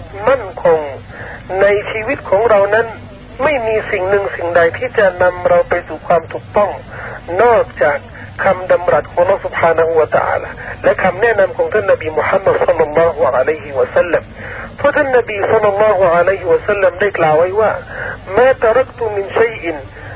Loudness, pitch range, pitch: -14 LUFS, 170-240 Hz, 200 Hz